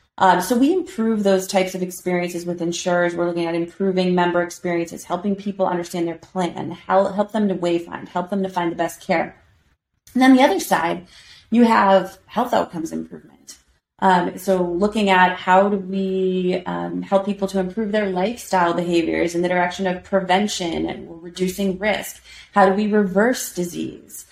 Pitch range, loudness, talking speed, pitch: 175-200 Hz, -20 LUFS, 175 wpm, 185 Hz